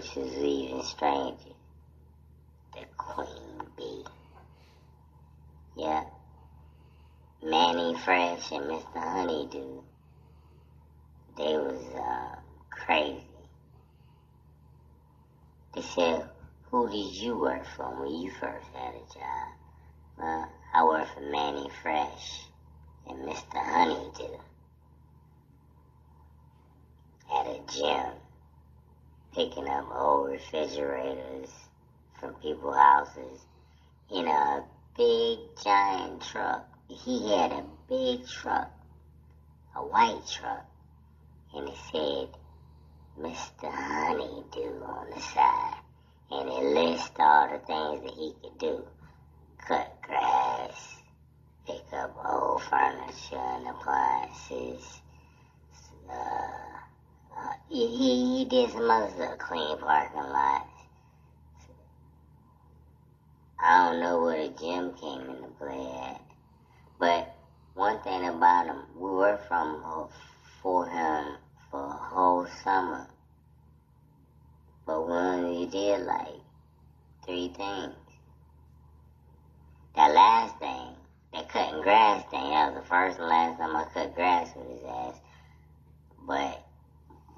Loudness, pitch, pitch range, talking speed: -29 LUFS, 75 Hz, 75-85 Hz, 105 wpm